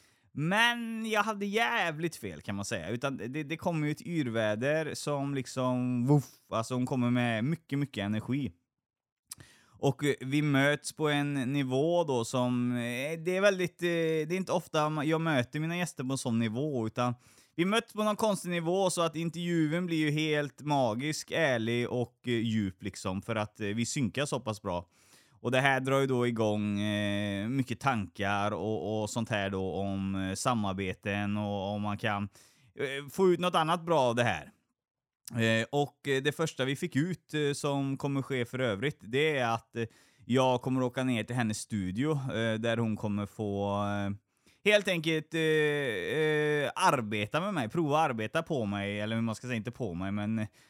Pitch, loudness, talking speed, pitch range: 130 Hz, -31 LUFS, 180 wpm, 110-155 Hz